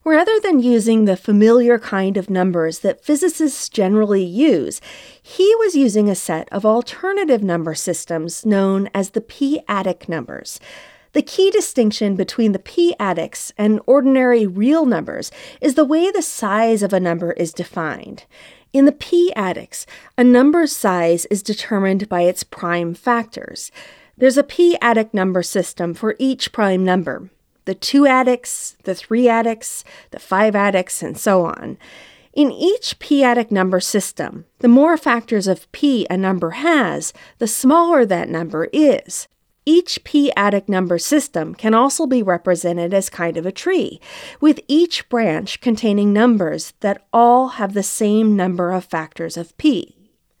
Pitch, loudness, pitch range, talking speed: 220 Hz, -17 LUFS, 190-280 Hz, 150 wpm